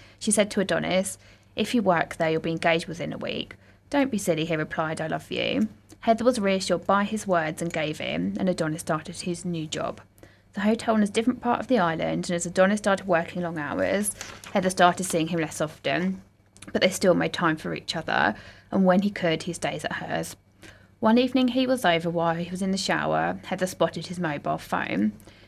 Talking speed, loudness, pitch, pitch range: 215 wpm, -25 LUFS, 180 Hz, 165-205 Hz